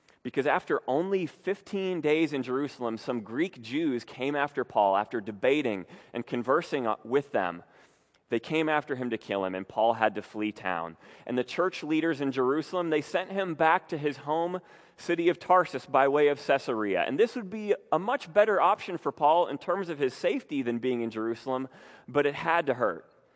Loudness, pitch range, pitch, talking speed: -29 LUFS, 120-175 Hz, 145 Hz, 195 wpm